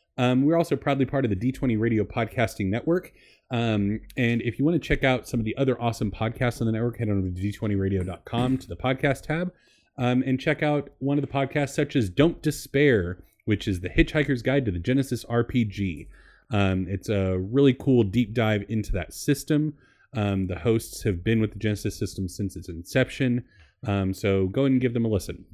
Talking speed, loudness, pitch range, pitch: 210 wpm, -25 LUFS, 100-135 Hz, 115 Hz